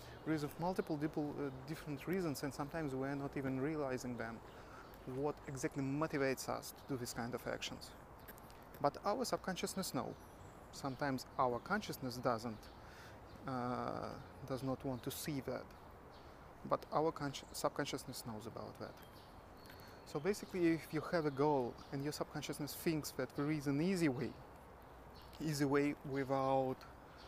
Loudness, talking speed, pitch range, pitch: -41 LUFS, 145 wpm, 125-155 Hz, 140 Hz